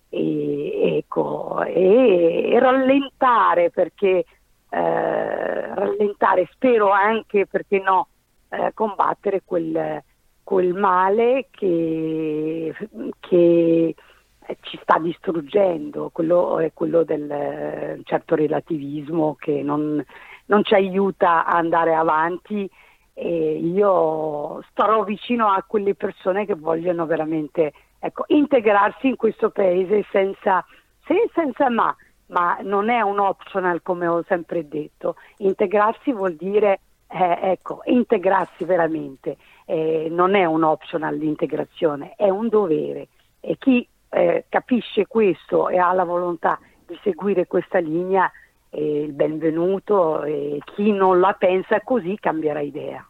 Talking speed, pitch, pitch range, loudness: 115 wpm, 185 Hz, 160-205 Hz, -20 LUFS